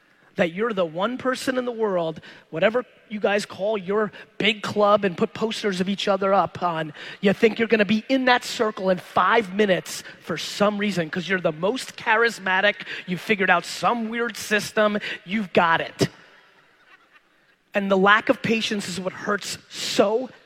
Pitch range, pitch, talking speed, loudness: 185-220 Hz, 205 Hz, 175 wpm, -22 LUFS